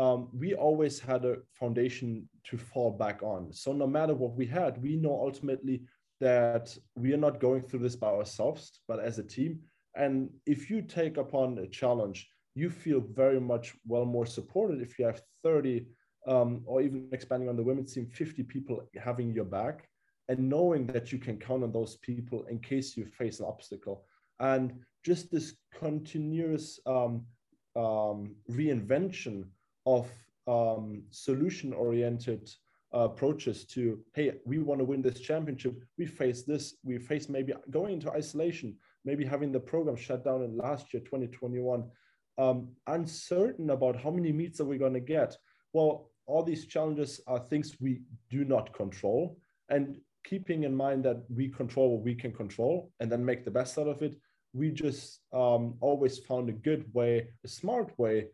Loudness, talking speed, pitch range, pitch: -32 LUFS, 175 wpm, 120-145 Hz, 130 Hz